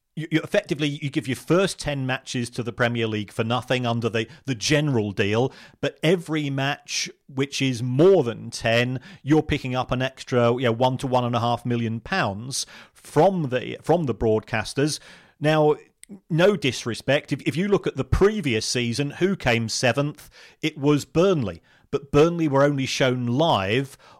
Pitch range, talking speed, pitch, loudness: 120-155 Hz, 180 wpm, 135 Hz, -23 LUFS